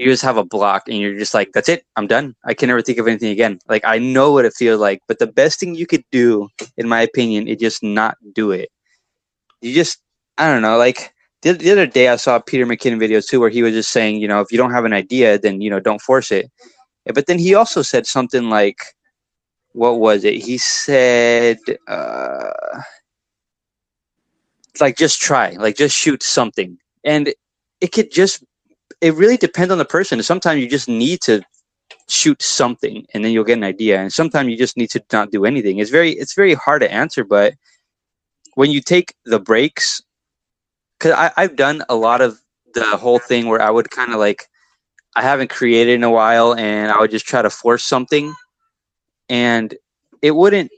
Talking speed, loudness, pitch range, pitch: 205 wpm, -15 LUFS, 110-150 Hz, 120 Hz